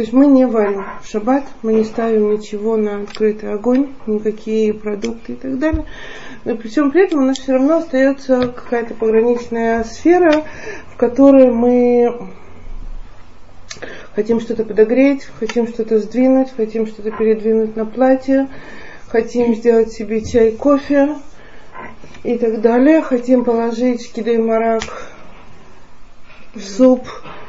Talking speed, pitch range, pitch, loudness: 130 wpm, 220-260 Hz, 235 Hz, -15 LUFS